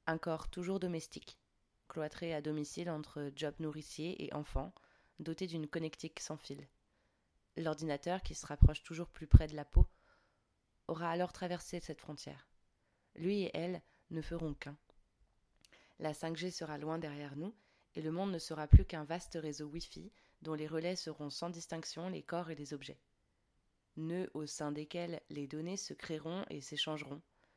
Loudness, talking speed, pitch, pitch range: -39 LUFS, 165 wpm, 155 Hz, 145-170 Hz